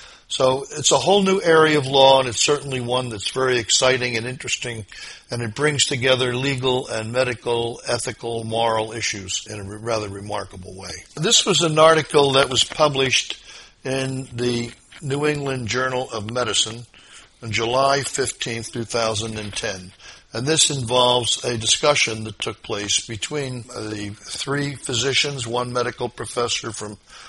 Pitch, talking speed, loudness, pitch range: 125 Hz, 145 wpm, -20 LUFS, 110-135 Hz